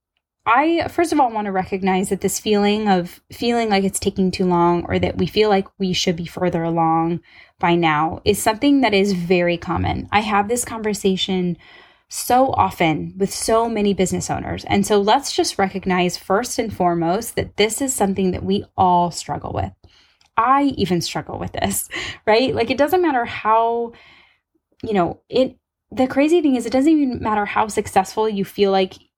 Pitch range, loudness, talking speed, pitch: 185-235 Hz, -19 LUFS, 185 wpm, 200 Hz